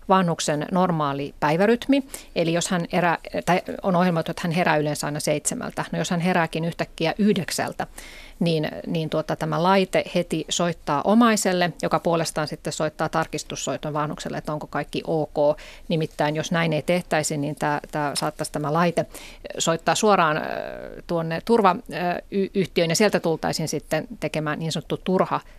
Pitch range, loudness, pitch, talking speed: 155-180 Hz, -23 LUFS, 165 Hz, 150 wpm